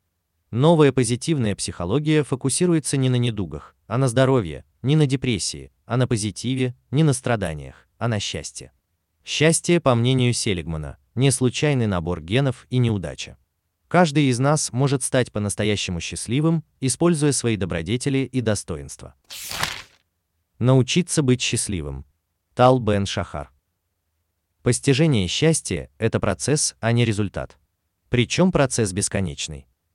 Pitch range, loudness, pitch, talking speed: 85-135 Hz, -21 LUFS, 115 Hz, 120 wpm